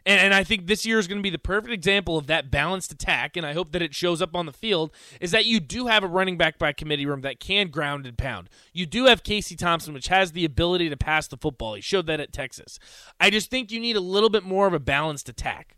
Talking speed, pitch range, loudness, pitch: 280 wpm, 155-200 Hz, -23 LUFS, 175 Hz